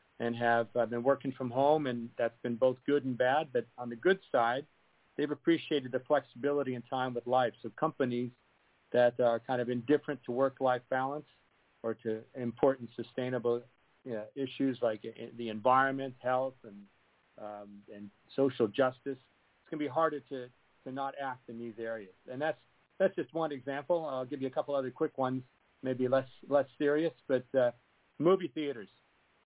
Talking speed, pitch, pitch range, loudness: 175 wpm, 130 Hz, 120-140 Hz, -33 LUFS